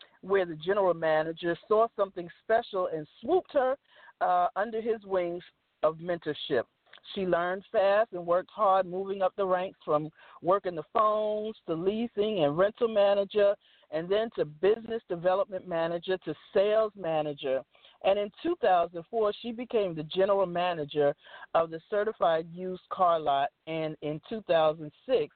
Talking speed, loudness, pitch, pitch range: 145 wpm, -29 LUFS, 185 Hz, 165-210 Hz